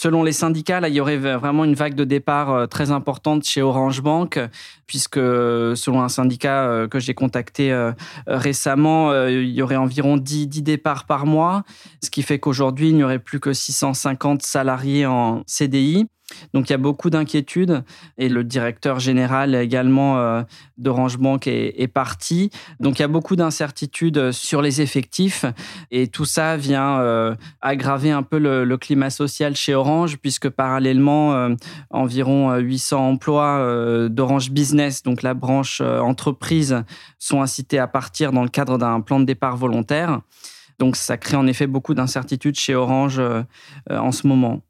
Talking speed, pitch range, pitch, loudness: 170 wpm, 130-150 Hz, 135 Hz, -19 LUFS